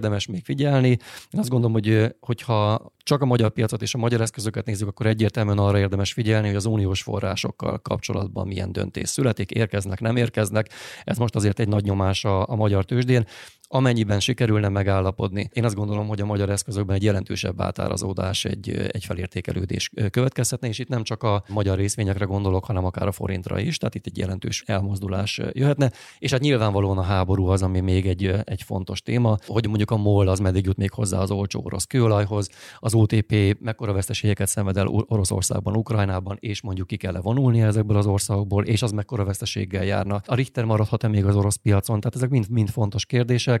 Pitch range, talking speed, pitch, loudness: 100-115 Hz, 190 wpm, 105 Hz, -23 LUFS